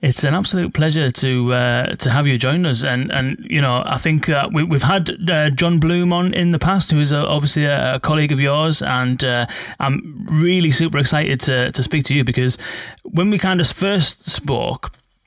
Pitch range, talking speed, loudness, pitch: 130-170 Hz, 215 wpm, -17 LUFS, 150 Hz